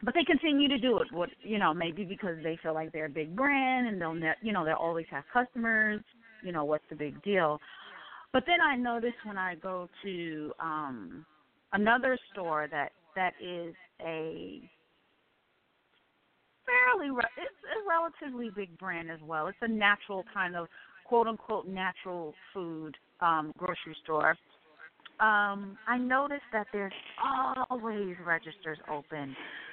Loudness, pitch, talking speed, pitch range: -31 LUFS, 190 Hz, 155 wpm, 165-235 Hz